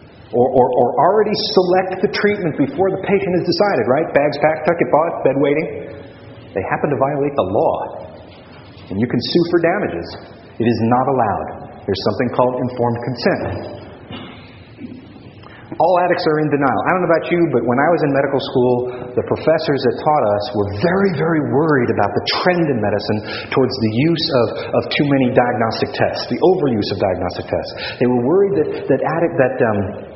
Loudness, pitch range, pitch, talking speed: -17 LUFS, 120-170 Hz, 135 Hz, 185 wpm